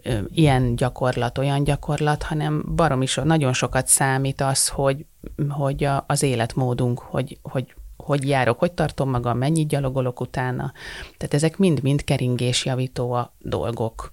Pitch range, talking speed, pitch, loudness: 125-150 Hz, 130 wpm, 135 Hz, -22 LUFS